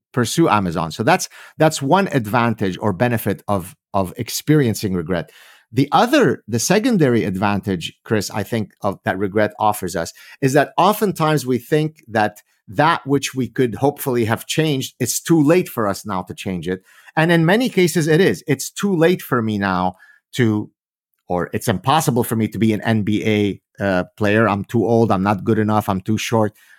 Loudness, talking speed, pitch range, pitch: -18 LUFS, 185 wpm, 100-140 Hz, 115 Hz